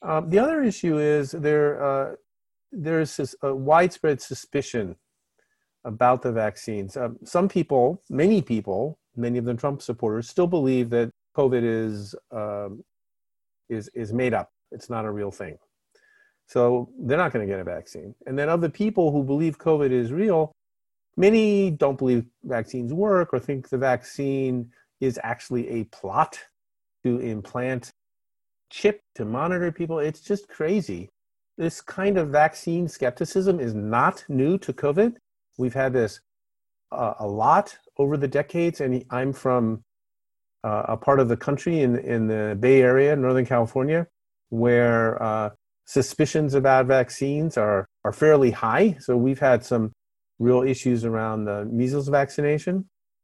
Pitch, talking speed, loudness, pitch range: 130 Hz, 150 wpm, -23 LUFS, 120-160 Hz